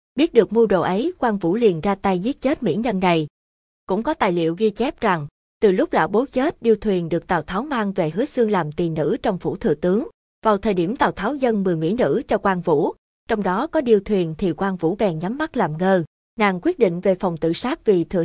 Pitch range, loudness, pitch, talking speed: 180-235 Hz, -21 LUFS, 205 Hz, 255 wpm